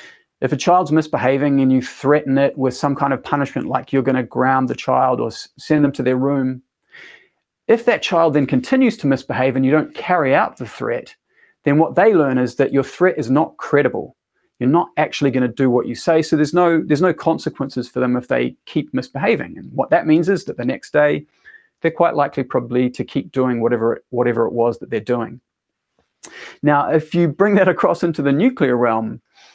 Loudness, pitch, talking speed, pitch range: -18 LUFS, 140 Hz, 215 wpm, 130-165 Hz